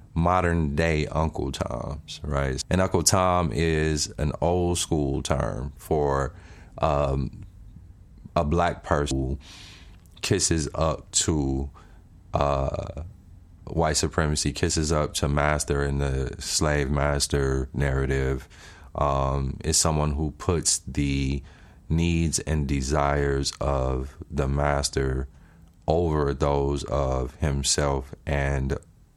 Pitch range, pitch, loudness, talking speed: 70-85 Hz, 75 Hz, -25 LUFS, 105 wpm